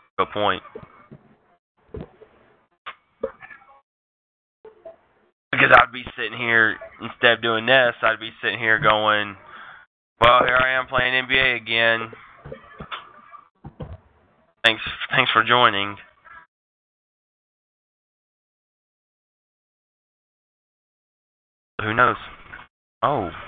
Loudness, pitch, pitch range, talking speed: -19 LUFS, 115 Hz, 100-130 Hz, 75 wpm